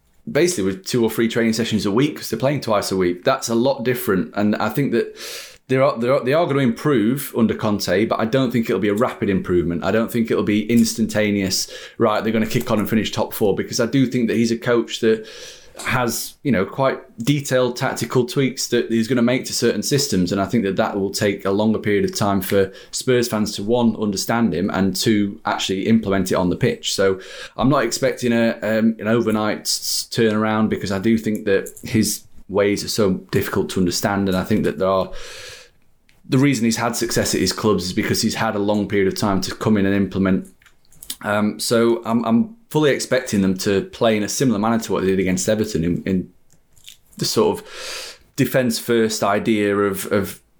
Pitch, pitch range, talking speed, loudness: 110 Hz, 100-120 Hz, 220 wpm, -19 LUFS